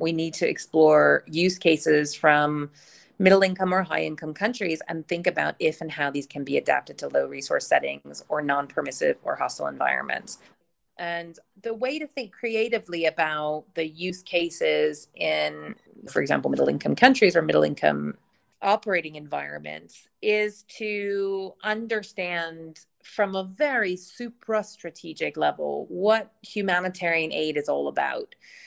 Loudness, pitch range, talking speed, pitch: -25 LUFS, 150-205 Hz, 145 wpm, 170 Hz